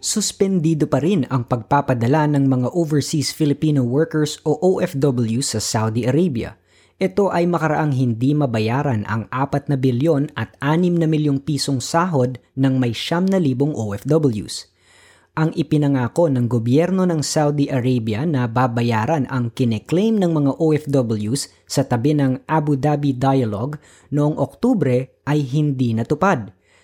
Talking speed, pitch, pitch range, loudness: 135 wpm, 140 Hz, 125-155 Hz, -19 LUFS